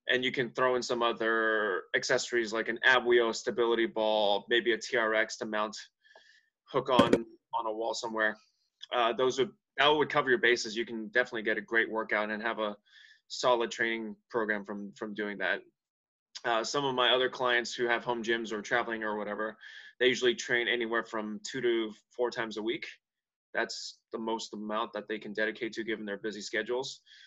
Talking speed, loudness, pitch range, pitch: 195 wpm, -30 LUFS, 110-120 Hz, 115 Hz